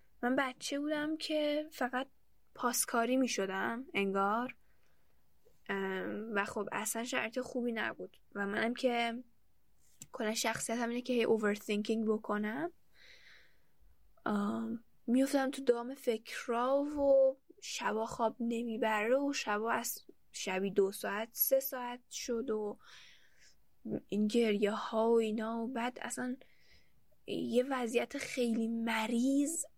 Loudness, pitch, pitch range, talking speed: -35 LUFS, 235 Hz, 220-260 Hz, 110 wpm